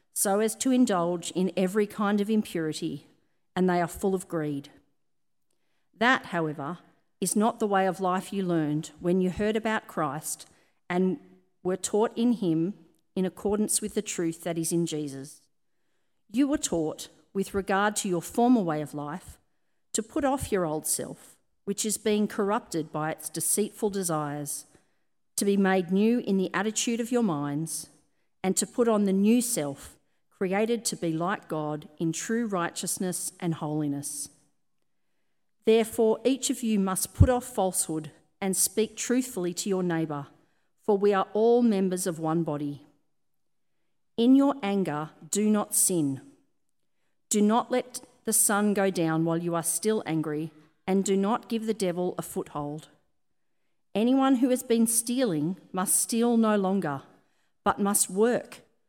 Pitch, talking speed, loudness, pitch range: 190 Hz, 160 wpm, -27 LUFS, 165-215 Hz